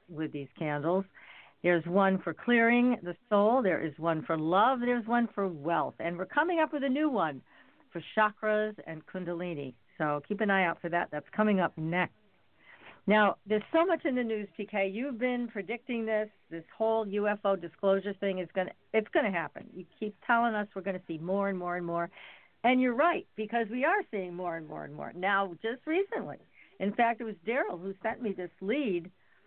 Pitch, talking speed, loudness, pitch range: 200 Hz, 205 wpm, -31 LUFS, 175-230 Hz